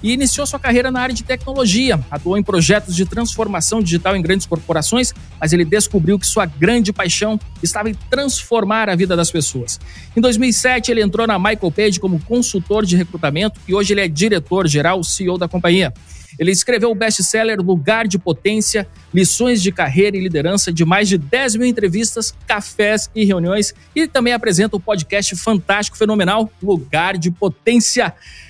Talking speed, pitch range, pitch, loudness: 175 wpm, 175-225 Hz, 200 Hz, -16 LUFS